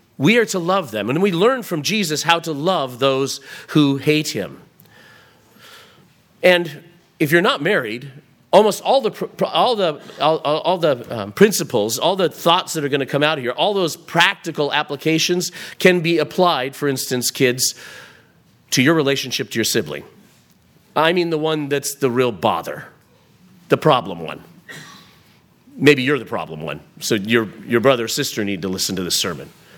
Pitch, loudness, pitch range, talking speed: 150 Hz, -18 LUFS, 135-175 Hz, 175 wpm